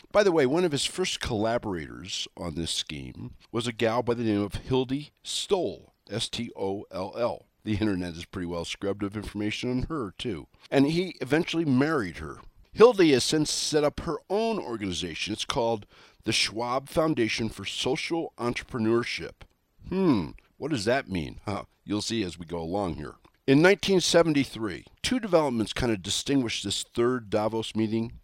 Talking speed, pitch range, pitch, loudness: 165 wpm, 100-140 Hz, 115 Hz, -27 LUFS